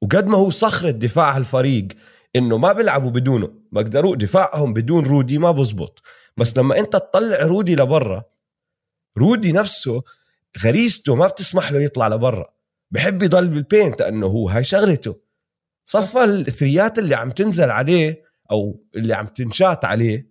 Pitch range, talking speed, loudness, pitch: 115-190 Hz, 140 wpm, -17 LUFS, 145 Hz